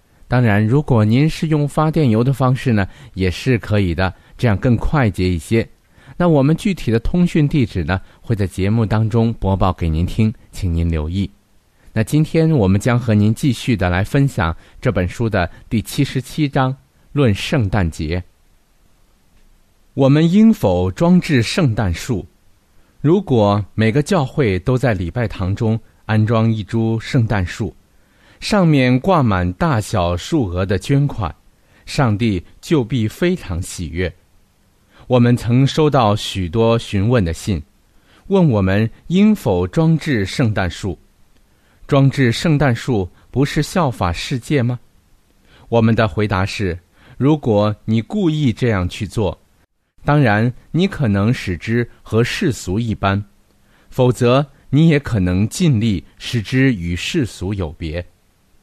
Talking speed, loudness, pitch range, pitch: 205 characters per minute, -17 LUFS, 95-135 Hz, 110 Hz